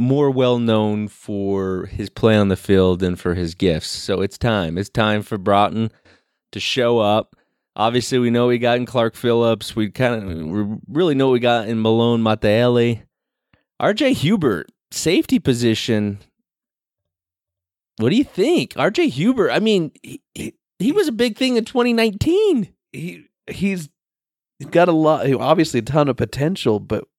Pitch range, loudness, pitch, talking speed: 105-155 Hz, -18 LUFS, 120 Hz, 170 wpm